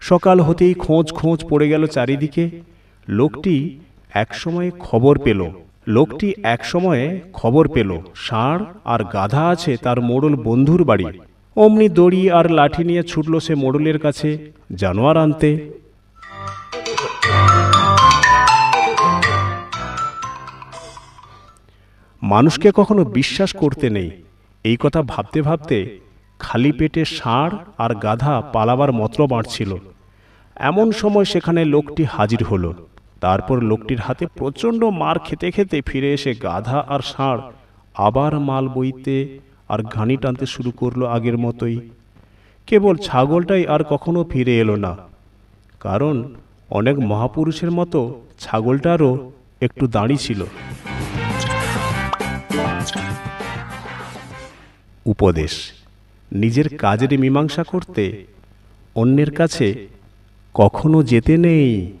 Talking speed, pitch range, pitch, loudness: 95 wpm, 105-160 Hz, 130 Hz, -17 LUFS